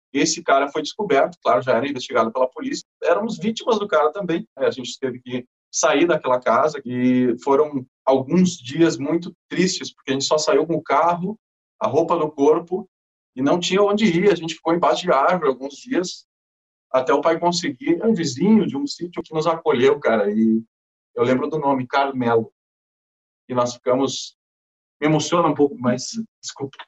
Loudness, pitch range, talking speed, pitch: -20 LUFS, 125-185 Hz, 185 wpm, 155 Hz